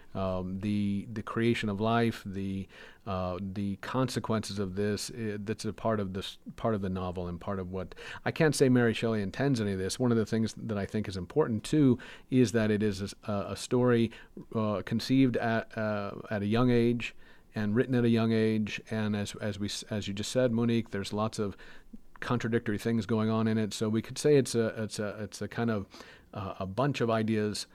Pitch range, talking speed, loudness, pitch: 100-115 Hz, 220 wpm, -31 LUFS, 110 Hz